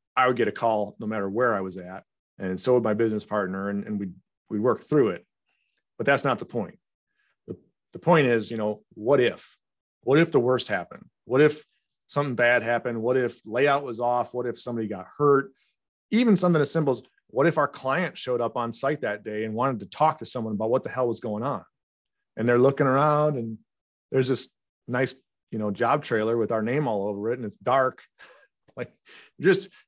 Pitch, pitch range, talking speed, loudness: 120 Hz, 110-135 Hz, 215 wpm, -25 LUFS